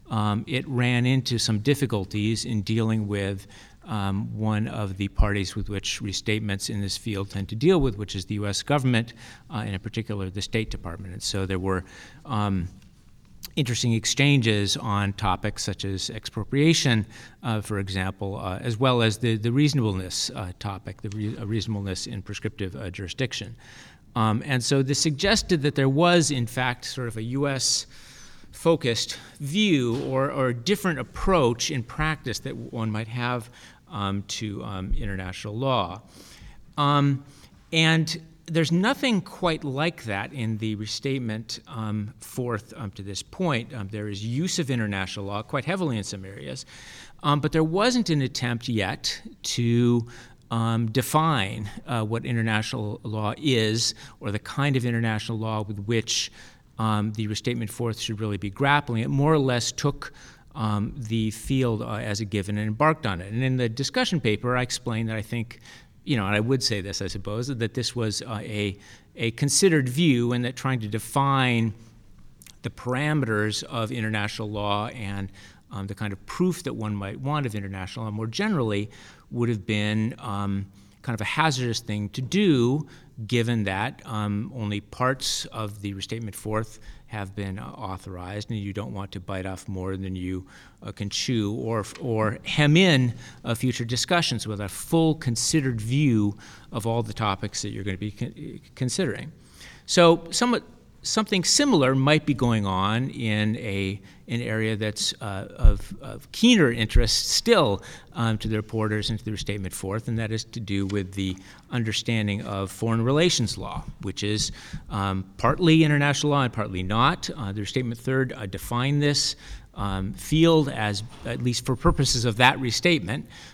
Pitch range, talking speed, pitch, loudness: 105-130 Hz, 170 wpm, 115 Hz, -25 LUFS